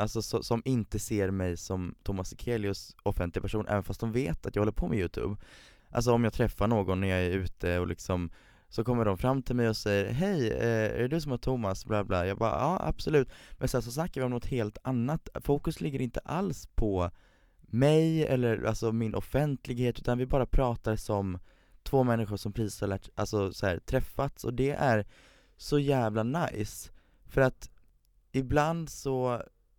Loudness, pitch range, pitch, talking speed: -31 LUFS, 100-130 Hz, 115 Hz, 190 wpm